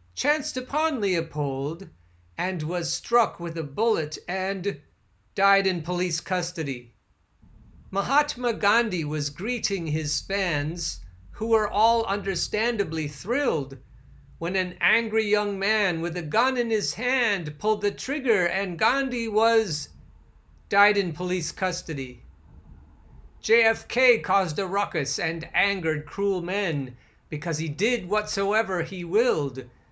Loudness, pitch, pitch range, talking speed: -25 LUFS, 185 Hz, 150-215 Hz, 120 wpm